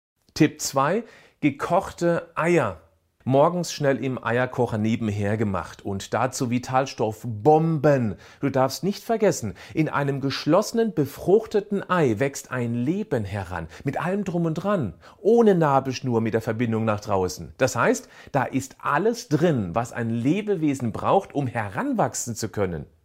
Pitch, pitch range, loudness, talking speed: 130 Hz, 110-165 Hz, -24 LUFS, 135 wpm